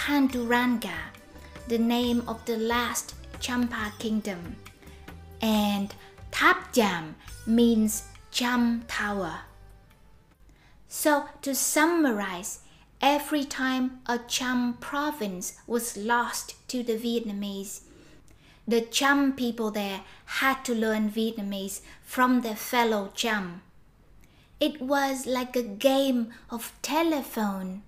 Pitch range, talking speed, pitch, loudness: 210-255 Hz, 100 wpm, 235 Hz, -27 LUFS